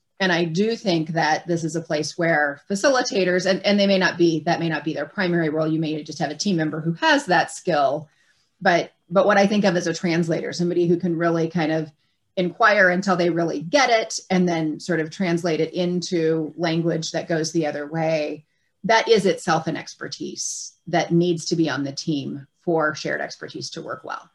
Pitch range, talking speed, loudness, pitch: 160-180 Hz, 215 wpm, -21 LUFS, 170 Hz